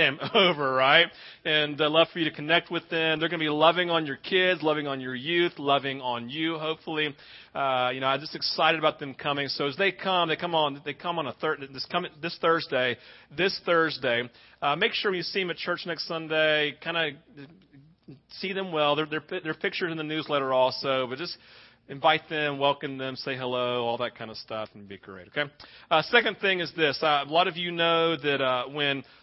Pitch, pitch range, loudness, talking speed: 155 Hz, 135-165 Hz, -26 LUFS, 220 wpm